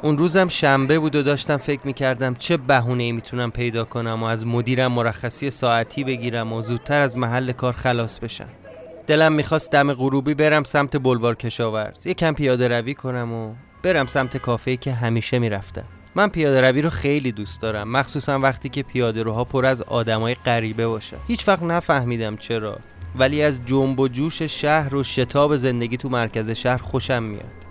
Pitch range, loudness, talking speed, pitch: 115-145 Hz, -21 LUFS, 180 wpm, 130 Hz